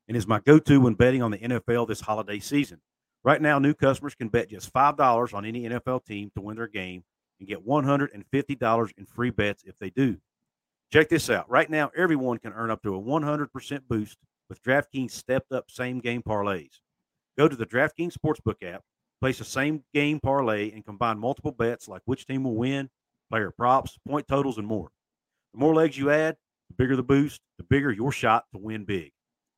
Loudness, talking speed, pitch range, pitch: -26 LUFS, 215 wpm, 110-140 Hz, 120 Hz